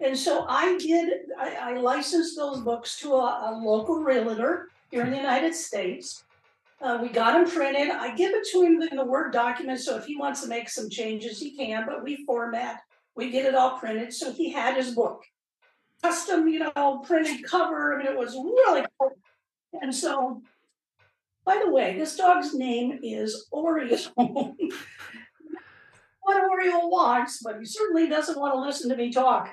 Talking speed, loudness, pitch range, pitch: 185 wpm, -26 LUFS, 245-330 Hz, 275 Hz